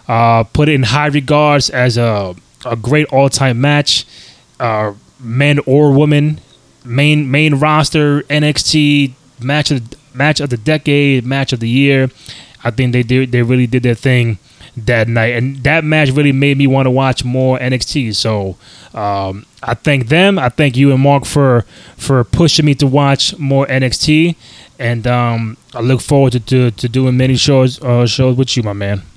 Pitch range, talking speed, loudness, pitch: 120-145 Hz, 180 wpm, -12 LUFS, 130 Hz